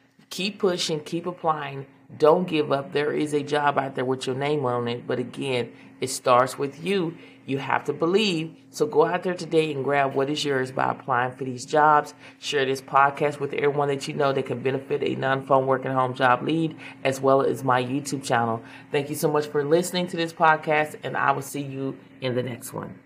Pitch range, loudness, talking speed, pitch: 135-155 Hz, -24 LUFS, 220 wpm, 140 Hz